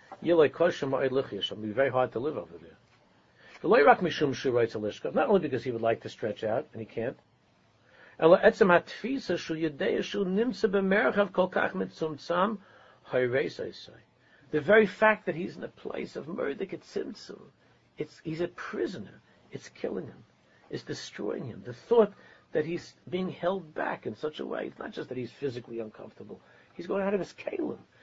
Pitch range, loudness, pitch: 130-200 Hz, -29 LUFS, 170 Hz